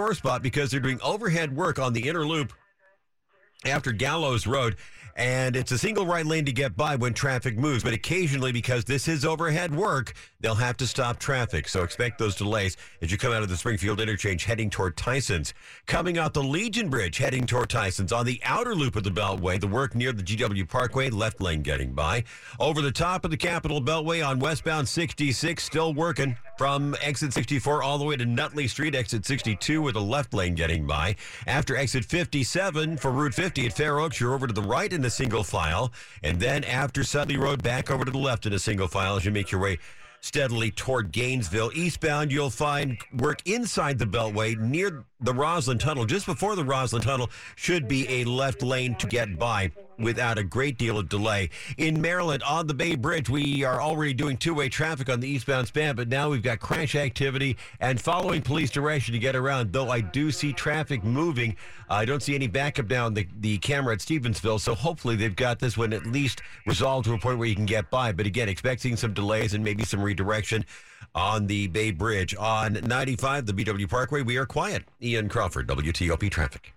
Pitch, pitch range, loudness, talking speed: 130 Hz, 110-145 Hz, -26 LUFS, 205 wpm